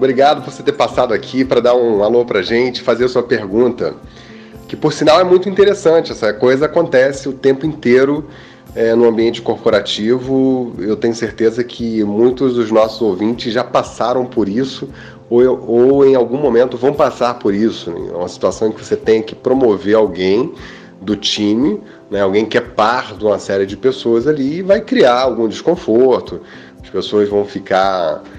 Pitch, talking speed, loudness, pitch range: 120 Hz, 185 wpm, -14 LUFS, 110-135 Hz